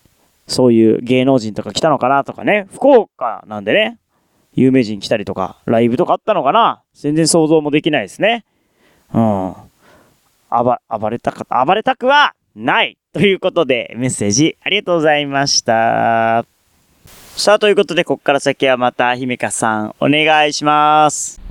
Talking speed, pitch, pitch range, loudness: 325 characters per minute, 140 Hz, 115-165 Hz, -14 LUFS